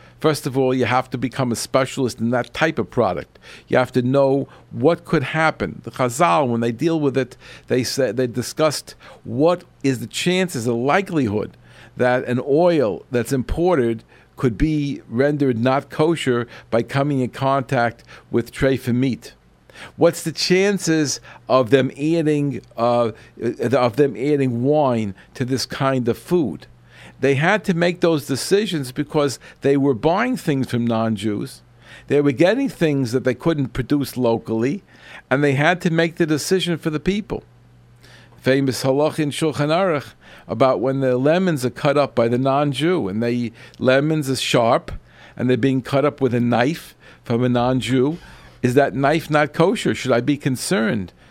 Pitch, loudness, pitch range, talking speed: 135 Hz, -20 LUFS, 120-150 Hz, 170 wpm